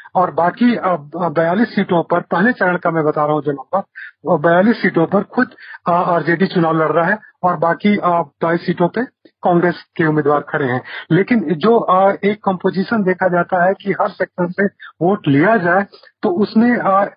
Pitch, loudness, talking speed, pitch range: 180 Hz, -16 LUFS, 180 wpm, 170-200 Hz